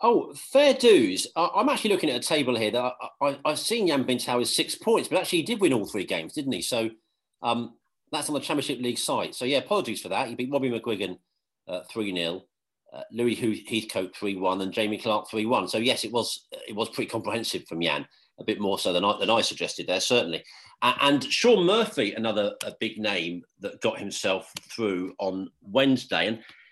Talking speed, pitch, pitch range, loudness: 215 wpm, 120 Hz, 110-160 Hz, -26 LUFS